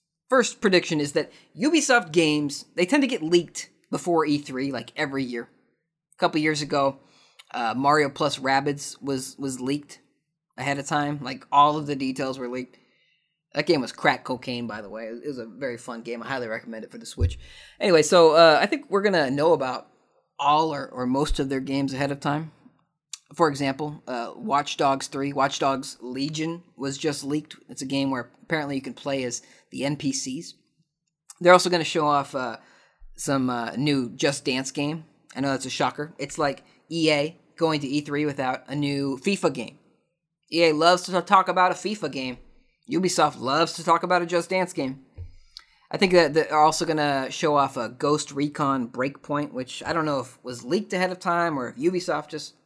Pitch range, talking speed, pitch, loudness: 135-165 Hz, 200 wpm, 145 Hz, -24 LUFS